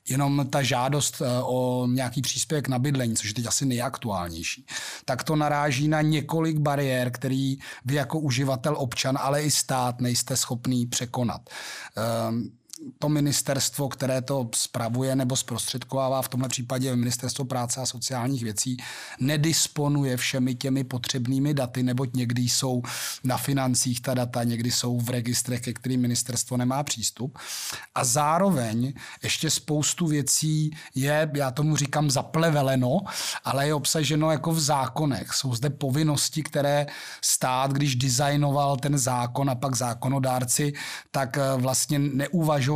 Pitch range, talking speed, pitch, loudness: 125-145 Hz, 140 wpm, 135 Hz, -25 LUFS